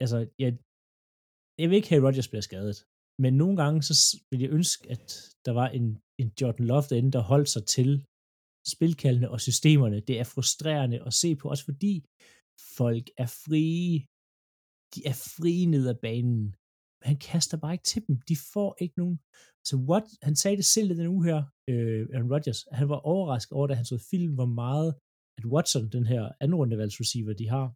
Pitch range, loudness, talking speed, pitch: 120-160 Hz, -27 LUFS, 190 wpm, 135 Hz